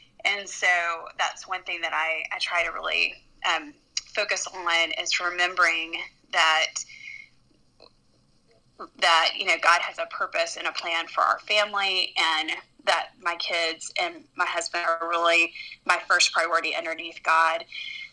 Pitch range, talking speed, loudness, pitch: 165-210 Hz, 145 wpm, -24 LUFS, 175 Hz